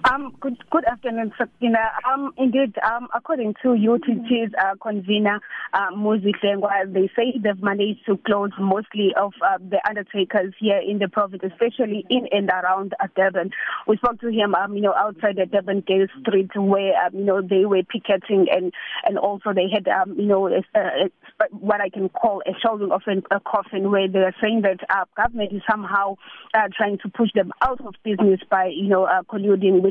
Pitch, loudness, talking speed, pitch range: 205 Hz, -21 LUFS, 195 wpm, 195-225 Hz